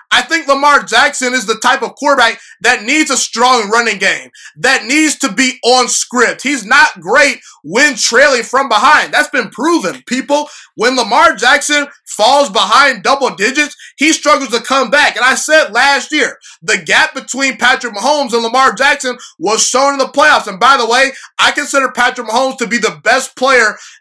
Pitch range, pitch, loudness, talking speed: 245-285 Hz, 265 Hz, -10 LUFS, 185 wpm